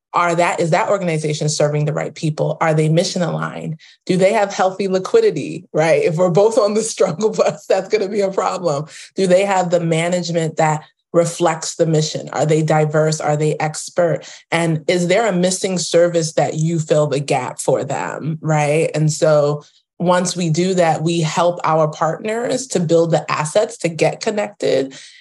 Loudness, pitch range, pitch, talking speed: -17 LUFS, 155-185 Hz, 170 Hz, 185 wpm